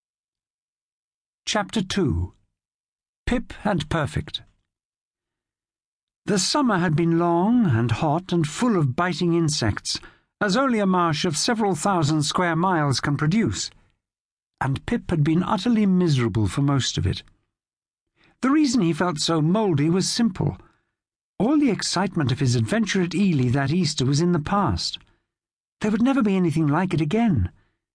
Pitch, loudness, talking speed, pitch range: 160 Hz, -22 LUFS, 145 wpm, 115-185 Hz